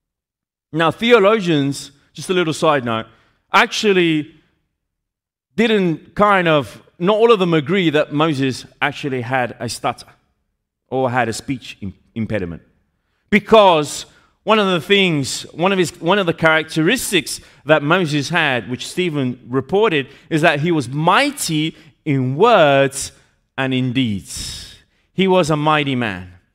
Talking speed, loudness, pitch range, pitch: 135 wpm, -17 LUFS, 120-170 Hz, 150 Hz